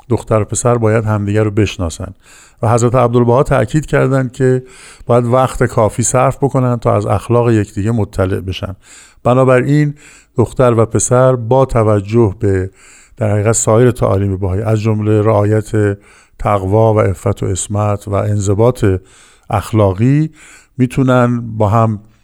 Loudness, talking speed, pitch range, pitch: -13 LUFS, 135 wpm, 105-125 Hz, 110 Hz